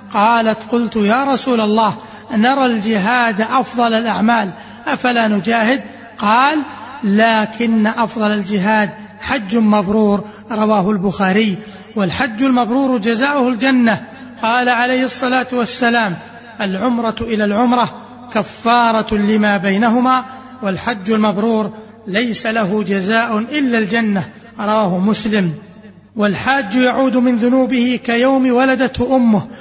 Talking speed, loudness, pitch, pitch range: 100 wpm, -15 LUFS, 225 Hz, 215-245 Hz